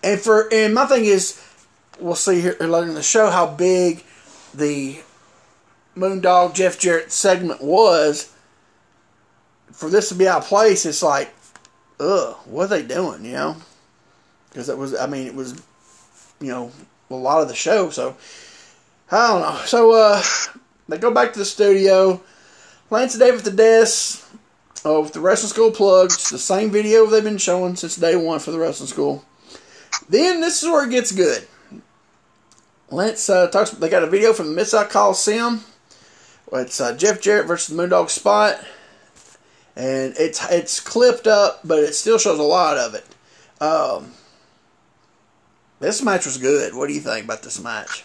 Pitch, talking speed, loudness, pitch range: 195 Hz, 175 wpm, -17 LUFS, 165-220 Hz